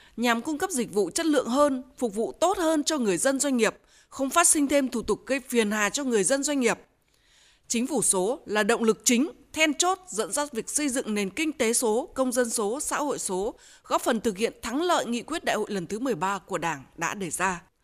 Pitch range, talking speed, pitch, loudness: 215-290 Hz, 245 wpm, 245 Hz, -26 LUFS